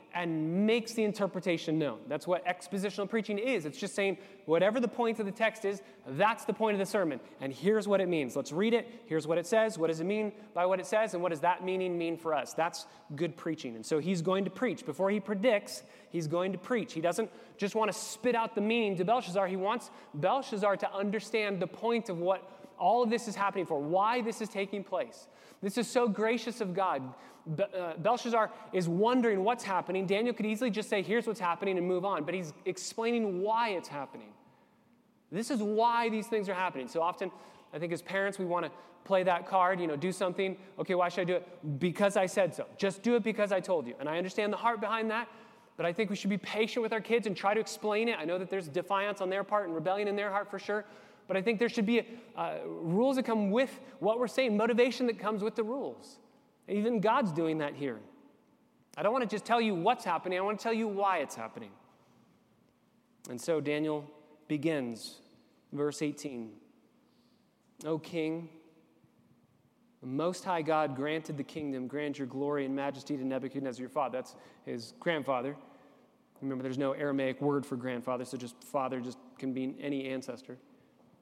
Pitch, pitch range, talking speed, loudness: 195 Hz, 165-220 Hz, 215 wpm, -32 LUFS